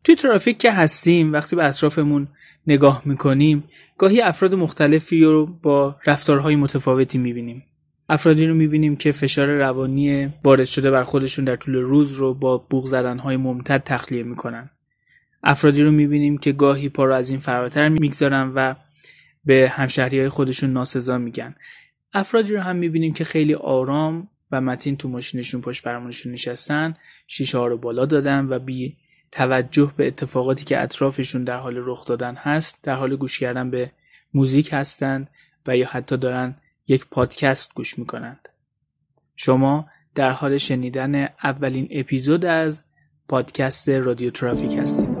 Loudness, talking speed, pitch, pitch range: -19 LUFS, 145 wpm, 135 Hz, 130-150 Hz